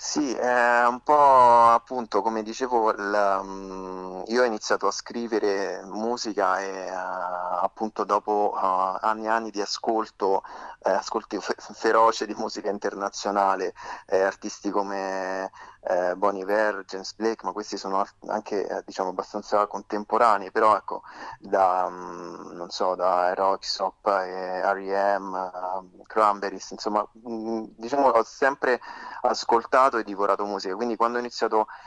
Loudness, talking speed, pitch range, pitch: -25 LUFS, 120 wpm, 95-115 Hz, 100 Hz